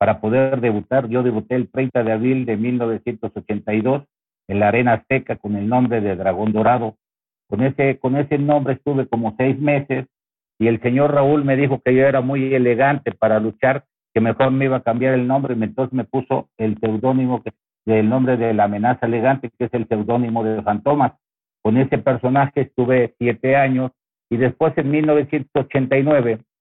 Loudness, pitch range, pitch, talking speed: -19 LUFS, 115-135 Hz, 125 Hz, 180 wpm